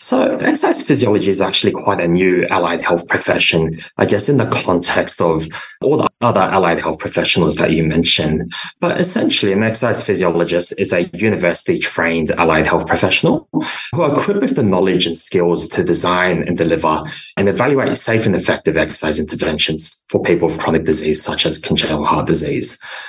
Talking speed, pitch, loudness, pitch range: 175 wpm, 85 Hz, -14 LUFS, 80-100 Hz